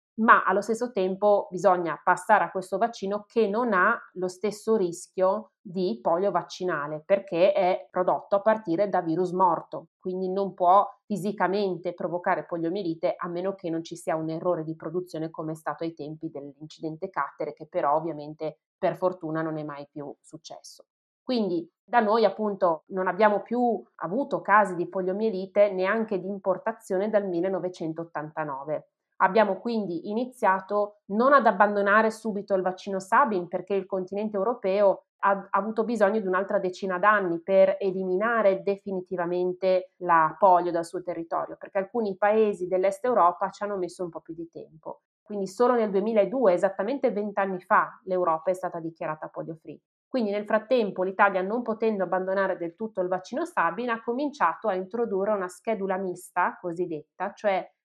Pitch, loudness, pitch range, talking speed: 190 Hz, -26 LUFS, 175-205 Hz, 160 wpm